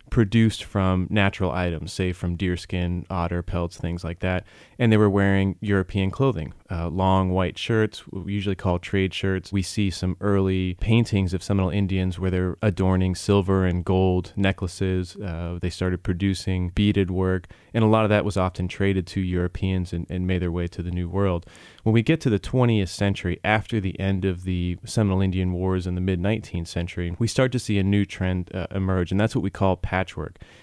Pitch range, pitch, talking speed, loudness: 90-100 Hz, 95 Hz, 205 wpm, -24 LUFS